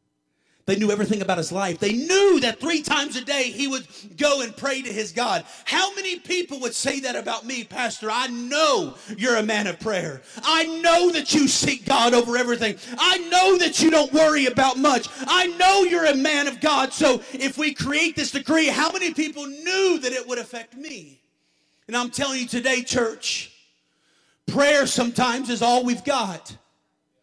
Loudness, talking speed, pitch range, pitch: -21 LUFS, 190 wpm, 235-305 Hz, 265 Hz